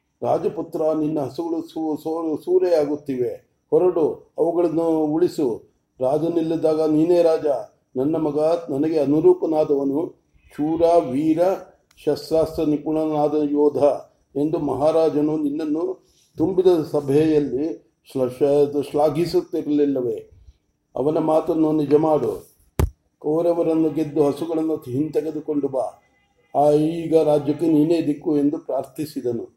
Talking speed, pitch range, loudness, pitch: 90 wpm, 150-165 Hz, -21 LUFS, 155 Hz